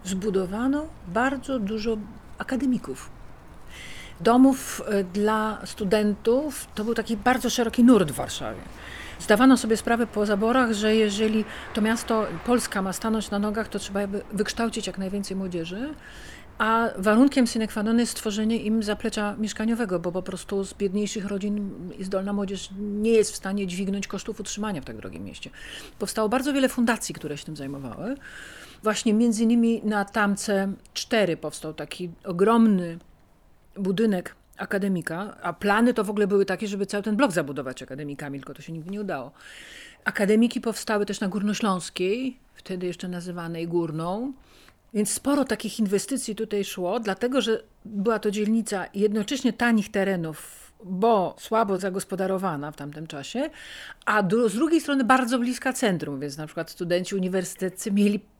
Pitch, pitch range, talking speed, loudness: 210 Hz, 190-230 Hz, 150 wpm, -25 LUFS